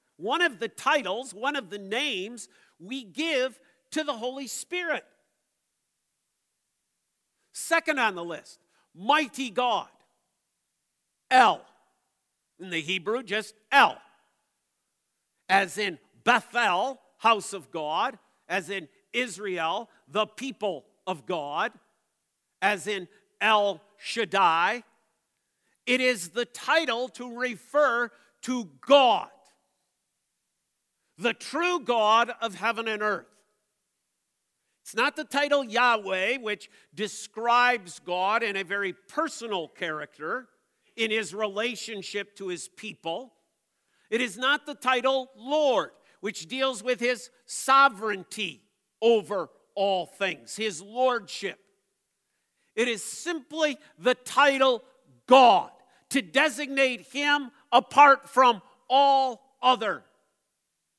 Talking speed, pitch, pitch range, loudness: 105 wpm, 230 Hz, 200-260 Hz, -26 LUFS